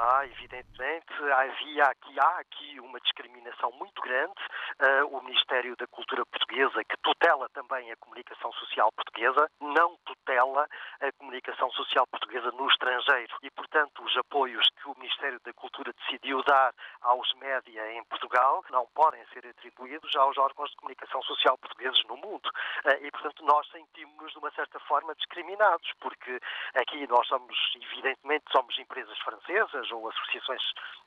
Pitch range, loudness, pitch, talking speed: 125-170 Hz, -28 LUFS, 140 Hz, 145 wpm